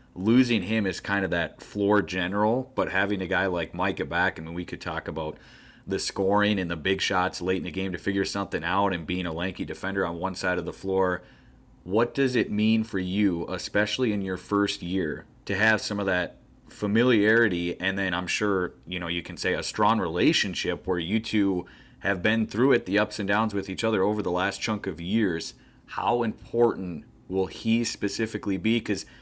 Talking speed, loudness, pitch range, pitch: 215 wpm, -26 LUFS, 90-105 Hz, 95 Hz